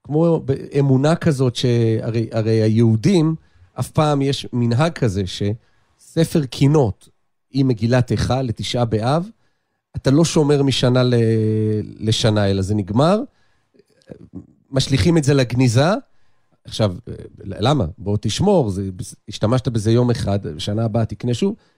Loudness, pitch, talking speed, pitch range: -18 LUFS, 120 Hz, 120 wpm, 110-140 Hz